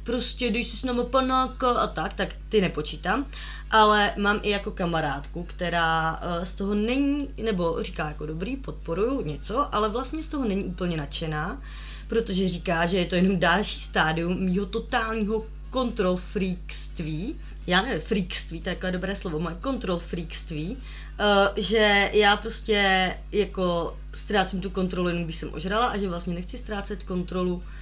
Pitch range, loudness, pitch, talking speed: 170-220 Hz, -26 LUFS, 190 Hz, 155 wpm